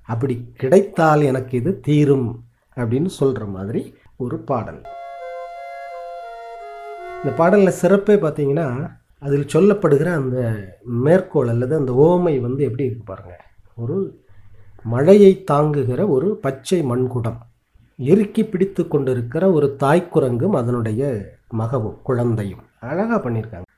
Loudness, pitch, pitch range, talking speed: -18 LUFS, 140 Hz, 120-175 Hz, 105 wpm